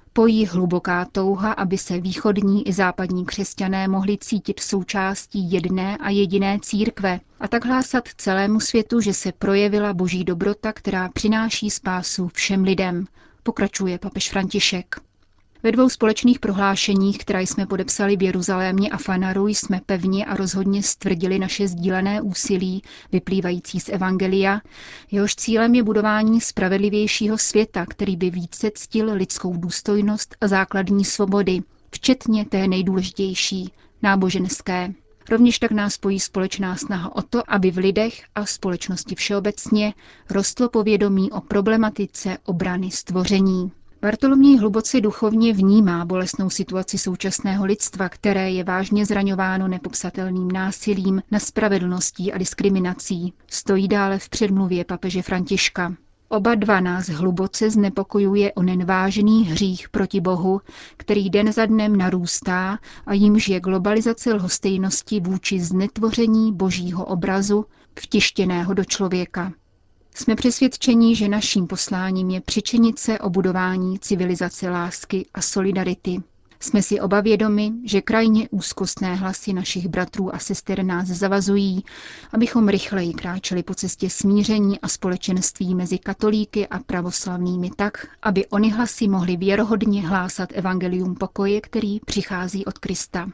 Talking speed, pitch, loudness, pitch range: 125 wpm, 195 Hz, -21 LUFS, 185-210 Hz